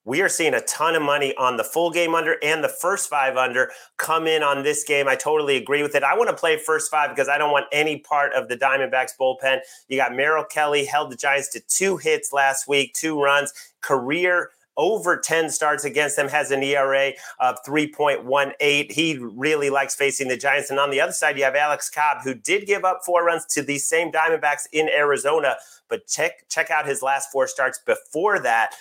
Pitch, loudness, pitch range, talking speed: 145 Hz, -21 LUFS, 135-155 Hz, 220 wpm